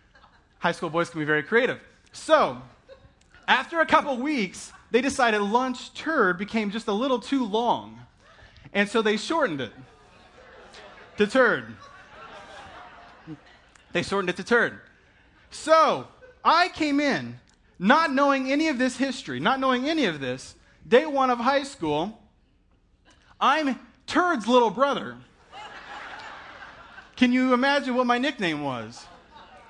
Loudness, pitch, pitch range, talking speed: -24 LUFS, 250 Hz, 200-280 Hz, 130 wpm